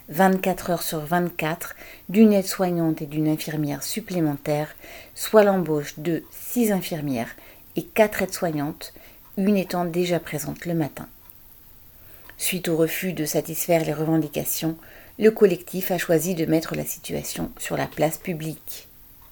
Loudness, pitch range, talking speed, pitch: -24 LUFS, 155-185 Hz, 135 wpm, 165 Hz